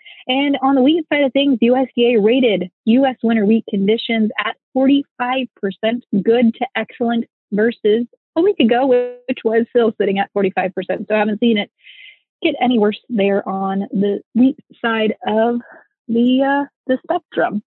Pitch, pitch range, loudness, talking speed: 240 Hz, 215-260 Hz, -17 LUFS, 160 wpm